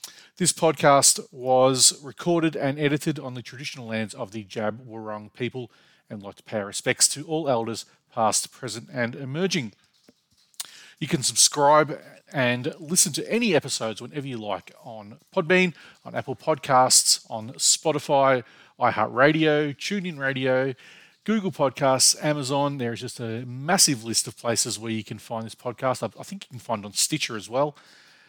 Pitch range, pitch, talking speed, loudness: 120-155 Hz, 130 Hz, 160 wpm, -23 LUFS